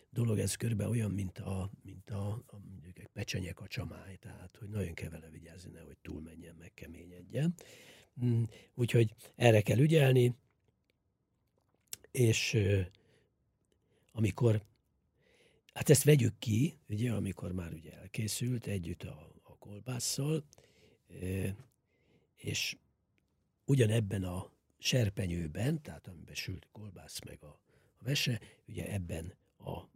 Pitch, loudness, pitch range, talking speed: 105 Hz, -33 LUFS, 90-120 Hz, 115 wpm